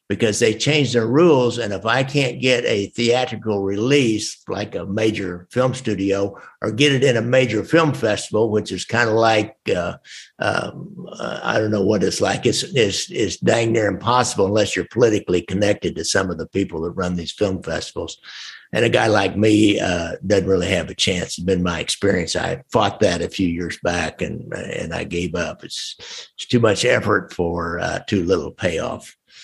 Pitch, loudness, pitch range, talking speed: 105 Hz, -19 LUFS, 95-120 Hz, 200 wpm